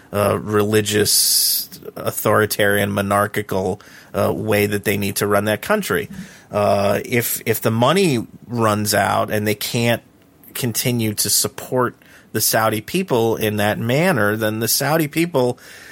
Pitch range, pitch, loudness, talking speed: 105-120 Hz, 110 Hz, -18 LUFS, 140 wpm